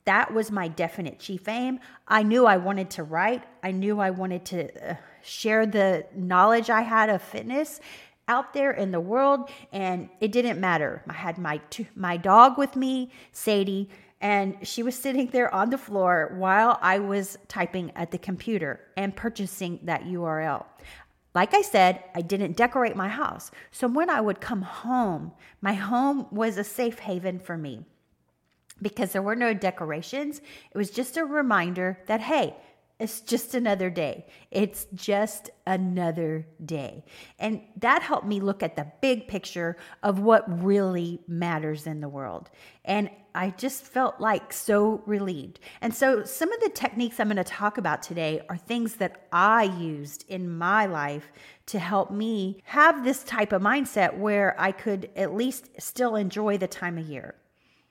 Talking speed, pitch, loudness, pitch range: 170 wpm, 200 Hz, -26 LUFS, 180-235 Hz